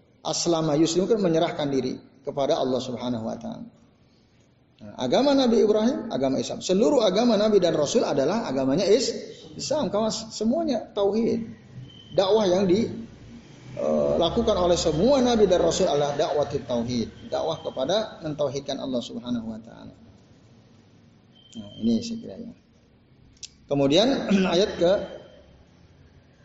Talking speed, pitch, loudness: 115 wpm, 180 Hz, -24 LUFS